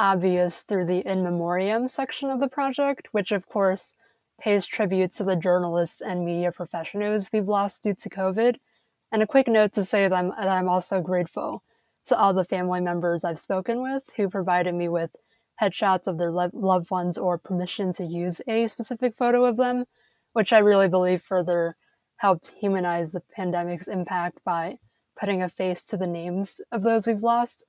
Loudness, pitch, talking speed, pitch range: -25 LUFS, 190 Hz, 185 wpm, 180-220 Hz